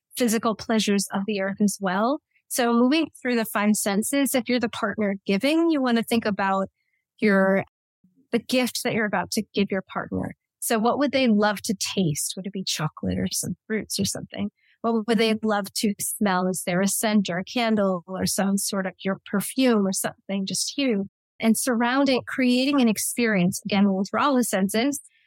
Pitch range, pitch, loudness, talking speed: 195-240 Hz, 215 Hz, -24 LUFS, 195 wpm